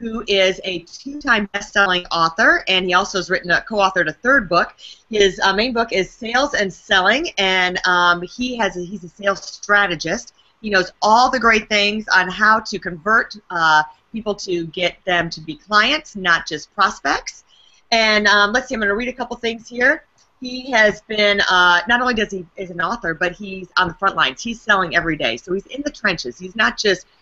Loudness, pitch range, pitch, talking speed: -17 LUFS, 180-225 Hz, 200 Hz, 205 wpm